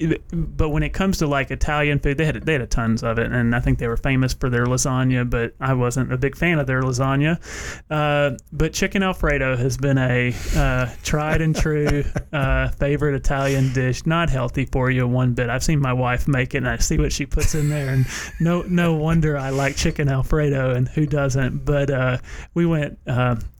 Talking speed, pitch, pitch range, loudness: 215 wpm, 140 Hz, 125-150 Hz, -21 LUFS